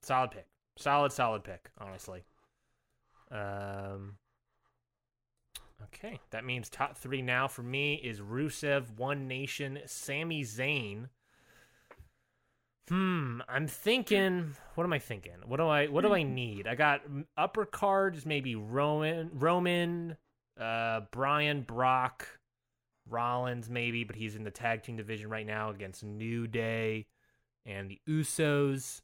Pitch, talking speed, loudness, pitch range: 130 Hz, 130 wpm, -33 LUFS, 110-145 Hz